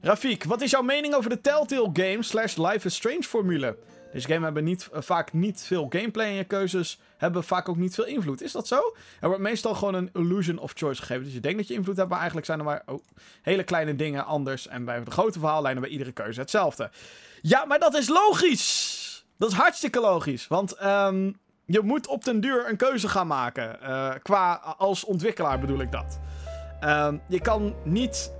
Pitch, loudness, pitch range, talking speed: 185 Hz, -26 LUFS, 155-225 Hz, 215 wpm